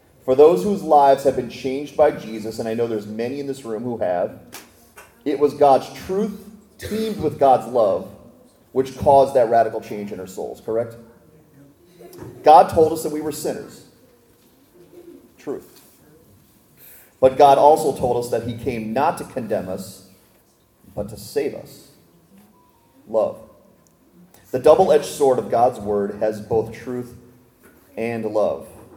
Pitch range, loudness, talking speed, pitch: 115-150 Hz, -19 LUFS, 150 wpm, 130 Hz